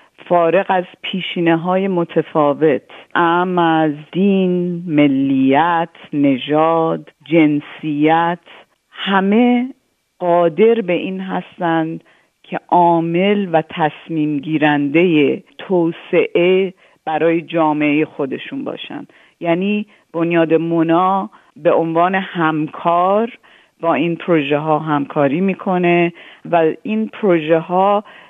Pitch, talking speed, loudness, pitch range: 170 Hz, 90 wpm, -16 LUFS, 155-185 Hz